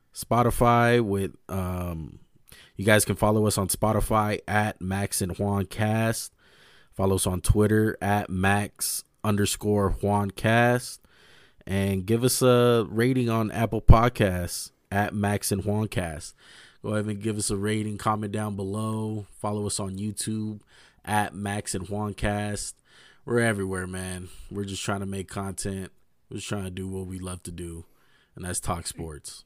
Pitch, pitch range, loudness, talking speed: 105 Hz, 95-110 Hz, -26 LUFS, 160 wpm